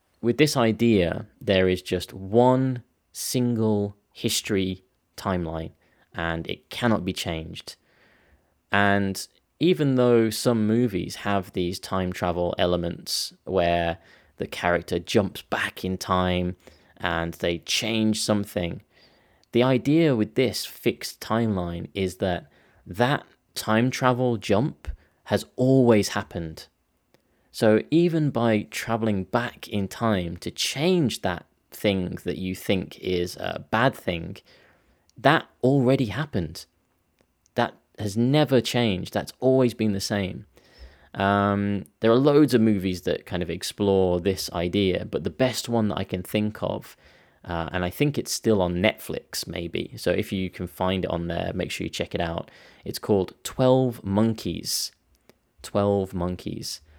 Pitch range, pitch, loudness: 90-115 Hz, 100 Hz, -25 LUFS